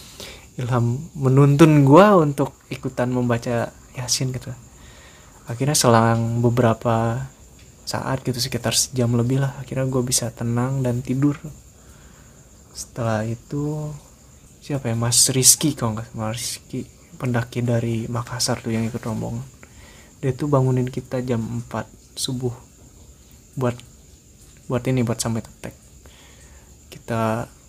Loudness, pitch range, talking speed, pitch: -20 LUFS, 115-130 Hz, 115 wpm, 125 Hz